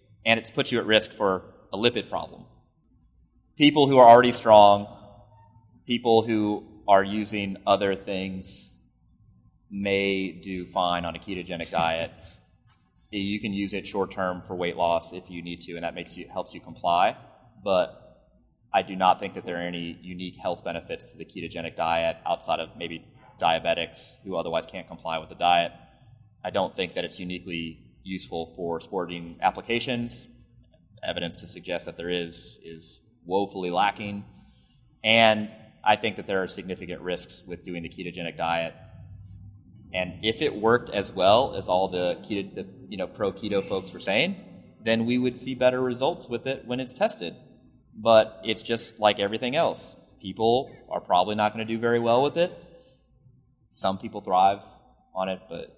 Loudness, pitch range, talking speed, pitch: -25 LUFS, 85-115 Hz, 170 wpm, 100 Hz